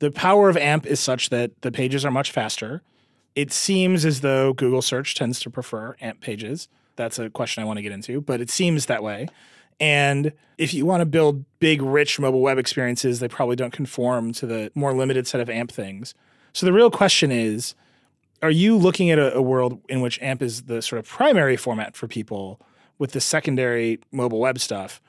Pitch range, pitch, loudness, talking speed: 120-150 Hz, 130 Hz, -21 LUFS, 210 wpm